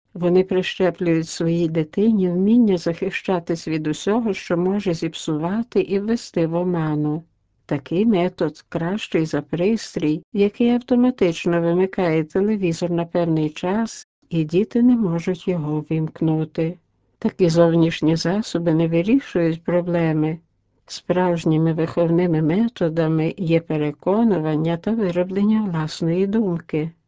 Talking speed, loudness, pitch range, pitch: 105 wpm, -20 LUFS, 165-195 Hz, 175 Hz